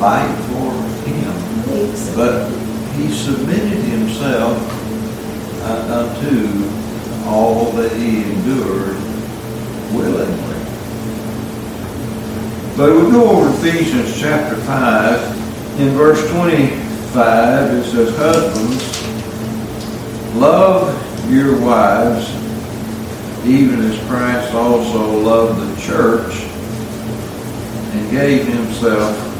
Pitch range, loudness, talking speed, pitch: 110-120 Hz, -16 LUFS, 80 wpm, 115 Hz